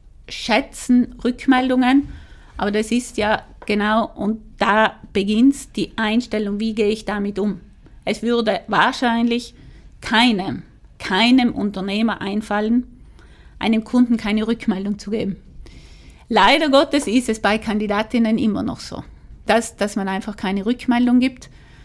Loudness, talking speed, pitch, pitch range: -19 LUFS, 125 wpm, 220 Hz, 210-245 Hz